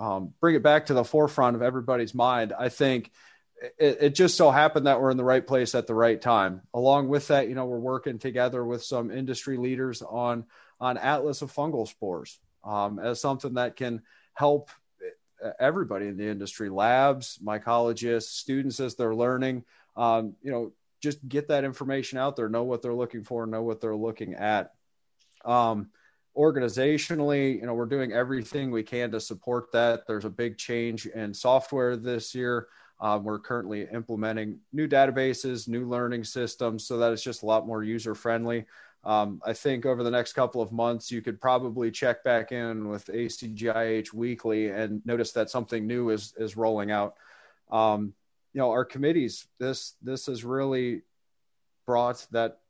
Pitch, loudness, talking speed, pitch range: 120 Hz, -27 LUFS, 180 wpm, 115-130 Hz